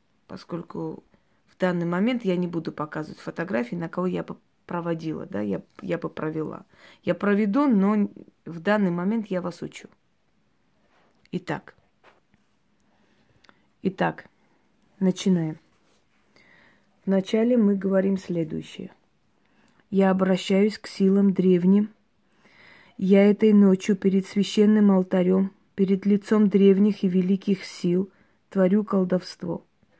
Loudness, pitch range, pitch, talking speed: -23 LUFS, 180-205 Hz, 195 Hz, 110 wpm